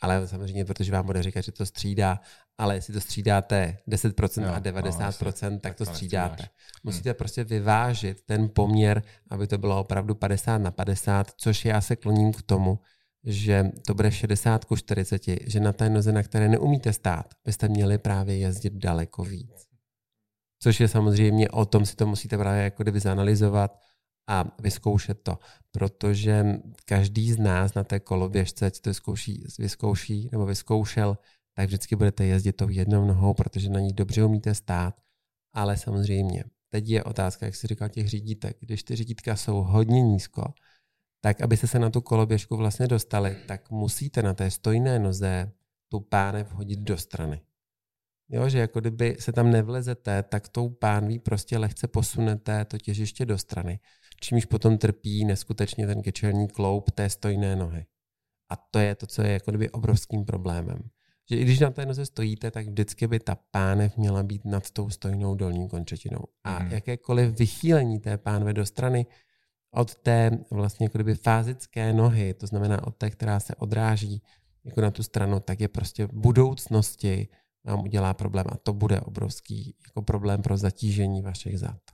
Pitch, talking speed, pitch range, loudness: 105 Hz, 170 wpm, 100-110 Hz, -26 LUFS